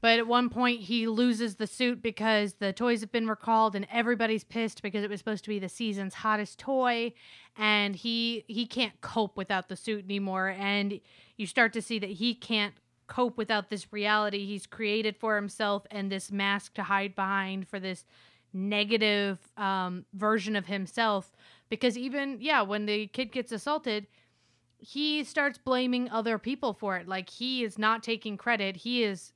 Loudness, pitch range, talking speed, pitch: -30 LUFS, 200-235 Hz, 180 wpm, 215 Hz